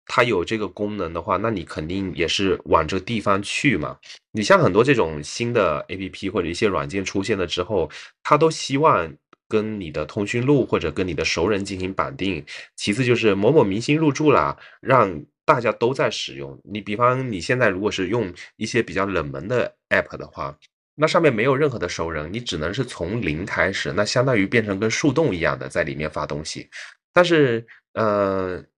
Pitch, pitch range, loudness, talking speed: 105 Hz, 90-120 Hz, -21 LUFS, 295 characters per minute